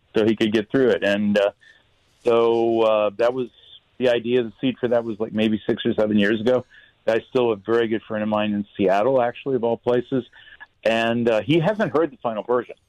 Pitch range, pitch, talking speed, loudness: 110-125 Hz, 115 Hz, 230 wpm, -21 LUFS